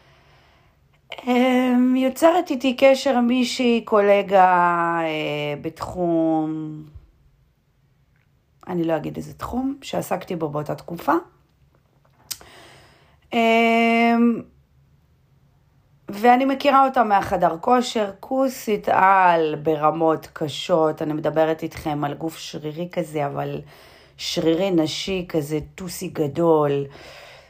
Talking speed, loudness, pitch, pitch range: 85 wpm, -20 LUFS, 170 Hz, 155-230 Hz